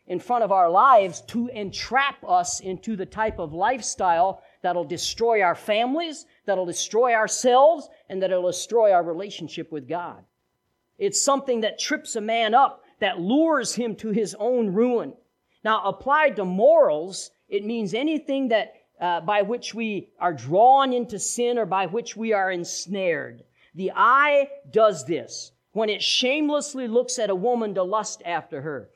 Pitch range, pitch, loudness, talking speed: 190-265 Hz, 220 Hz, -23 LUFS, 160 wpm